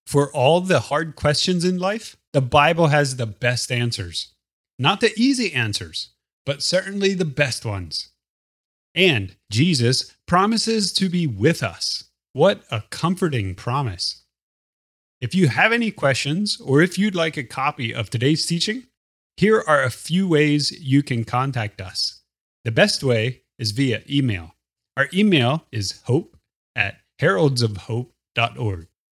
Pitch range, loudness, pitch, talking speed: 110-170 Hz, -21 LUFS, 140 Hz, 140 wpm